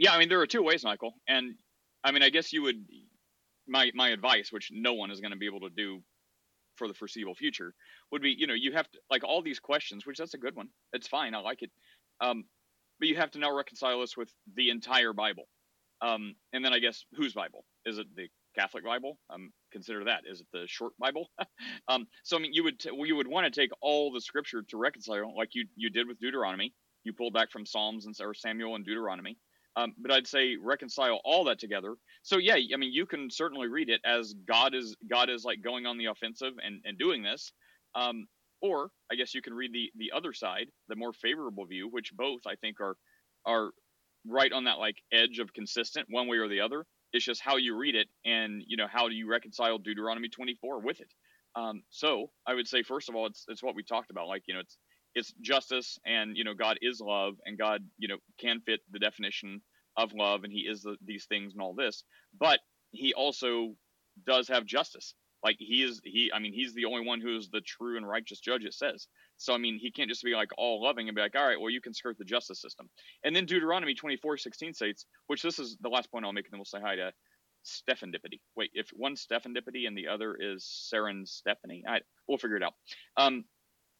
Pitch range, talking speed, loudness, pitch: 110-130 Hz, 235 wpm, -31 LUFS, 120 Hz